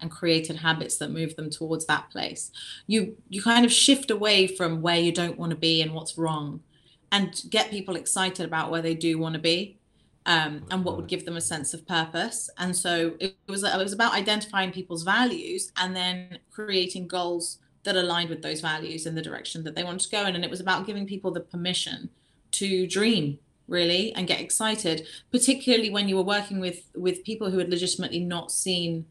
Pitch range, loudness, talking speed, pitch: 165-195 Hz, -26 LUFS, 210 wpm, 180 Hz